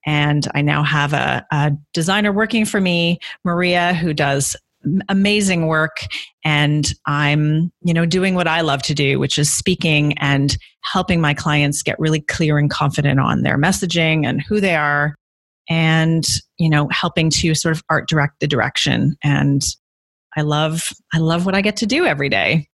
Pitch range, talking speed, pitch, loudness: 145-175 Hz, 175 wpm, 155 Hz, -17 LUFS